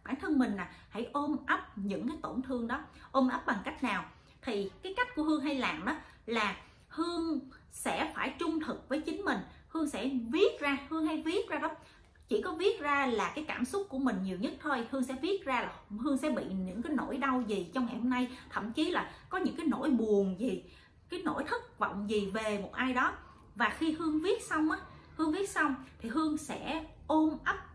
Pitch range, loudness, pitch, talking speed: 250-320 Hz, -34 LUFS, 285 Hz, 225 wpm